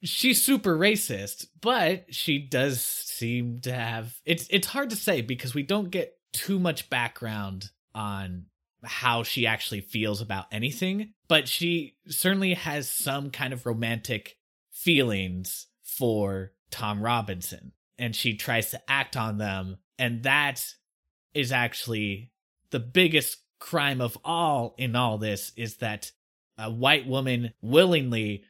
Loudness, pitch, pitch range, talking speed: -27 LUFS, 125 Hz, 110-155 Hz, 135 wpm